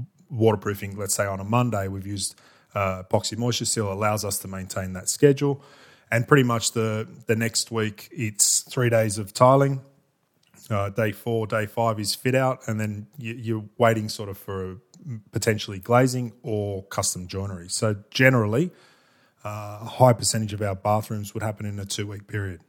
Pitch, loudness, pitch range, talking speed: 110 Hz, -24 LUFS, 100-120 Hz, 180 wpm